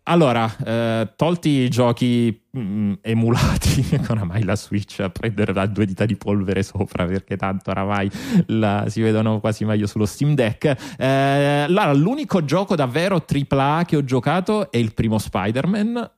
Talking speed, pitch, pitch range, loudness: 165 wpm, 115 Hz, 105-145 Hz, -20 LUFS